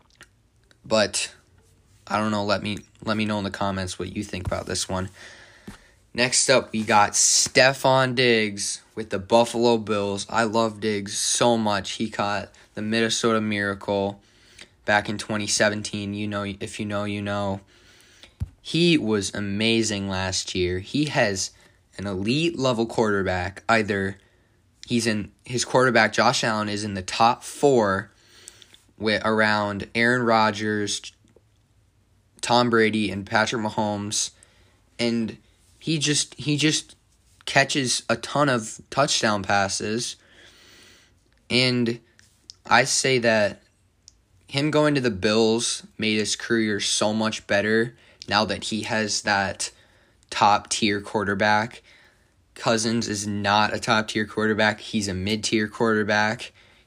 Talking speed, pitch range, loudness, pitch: 130 wpm, 100-115 Hz, -23 LUFS, 105 Hz